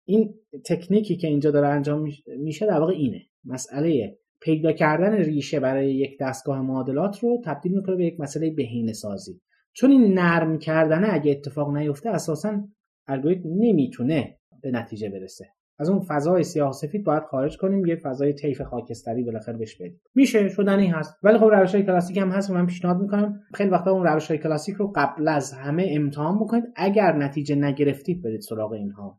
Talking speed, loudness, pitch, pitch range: 175 wpm, -23 LUFS, 155 Hz, 140-195 Hz